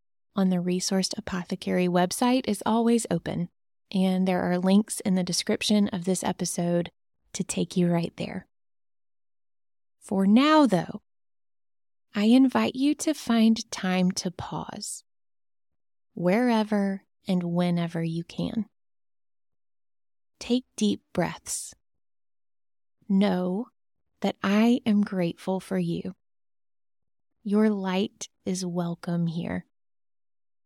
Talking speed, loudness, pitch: 105 wpm, -26 LUFS, 180 Hz